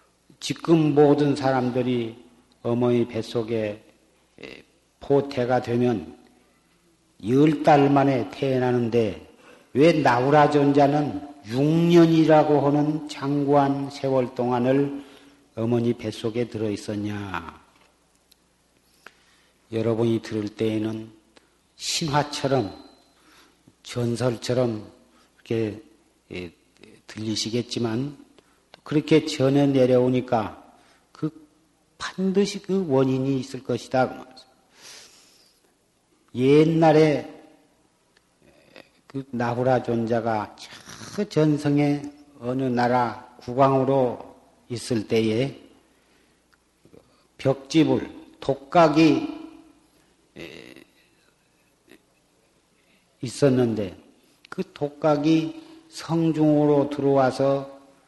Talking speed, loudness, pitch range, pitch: 160 characters per minute, -22 LUFS, 120-150 Hz, 135 Hz